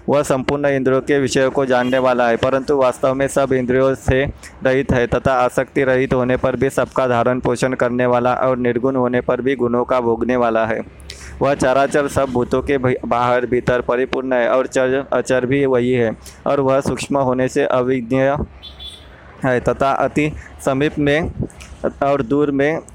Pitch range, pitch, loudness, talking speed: 125-135 Hz, 130 Hz, -17 LUFS, 180 wpm